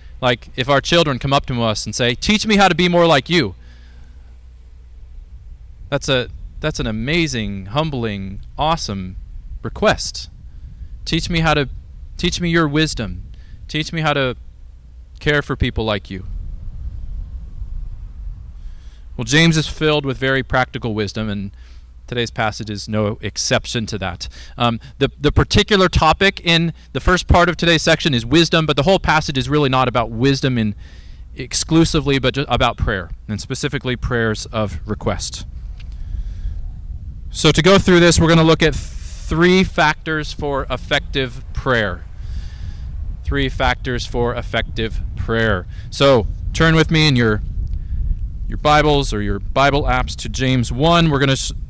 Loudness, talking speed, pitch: -17 LUFS, 155 wpm, 115 Hz